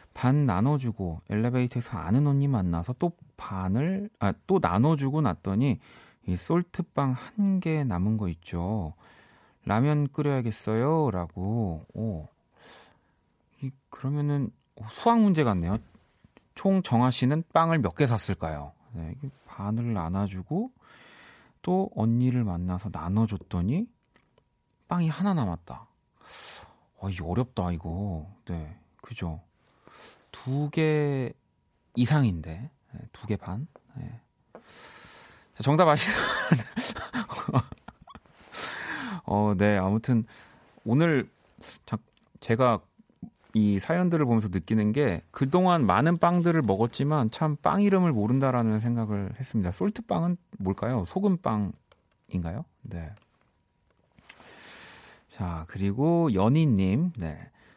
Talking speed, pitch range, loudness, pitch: 210 characters per minute, 100-150 Hz, -27 LUFS, 115 Hz